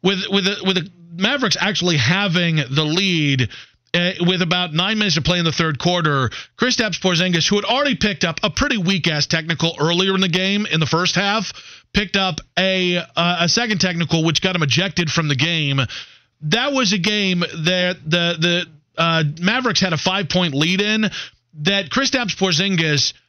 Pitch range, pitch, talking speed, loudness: 165-195 Hz, 180 Hz, 185 wpm, -18 LUFS